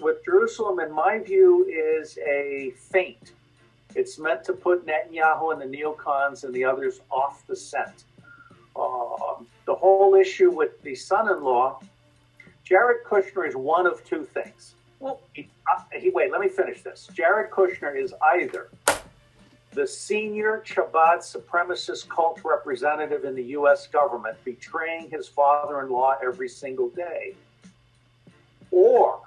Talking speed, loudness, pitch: 135 wpm, -24 LUFS, 190 Hz